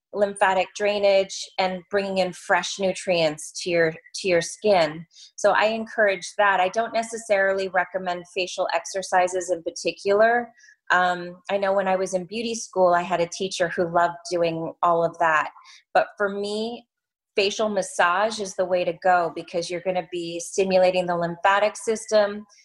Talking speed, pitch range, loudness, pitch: 165 wpm, 175-205 Hz, -23 LUFS, 185 Hz